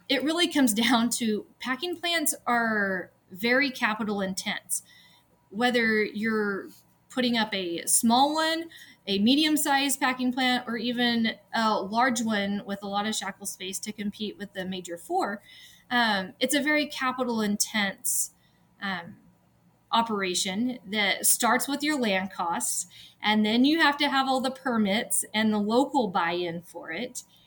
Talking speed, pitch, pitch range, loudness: 155 wpm, 230 Hz, 205-260 Hz, -26 LUFS